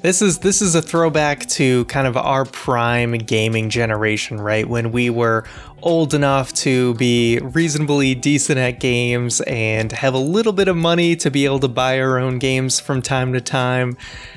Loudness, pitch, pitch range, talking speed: -17 LUFS, 130 Hz, 120-145 Hz, 185 wpm